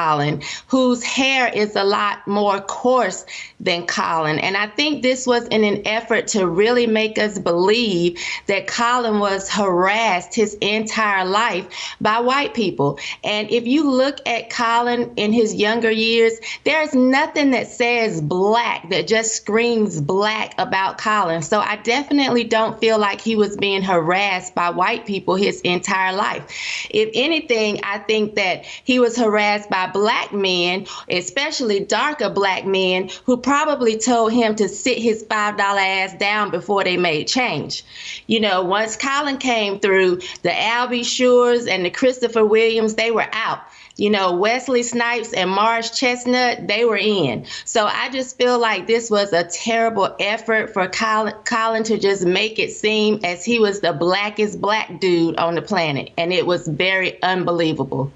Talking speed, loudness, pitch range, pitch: 165 wpm, -18 LUFS, 190-235 Hz, 215 Hz